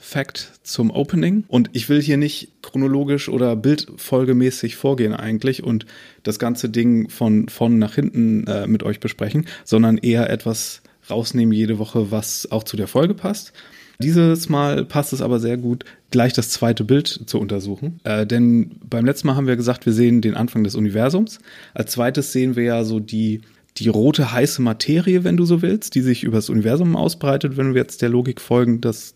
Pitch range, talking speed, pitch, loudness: 110-145 Hz, 190 wpm, 120 Hz, -19 LUFS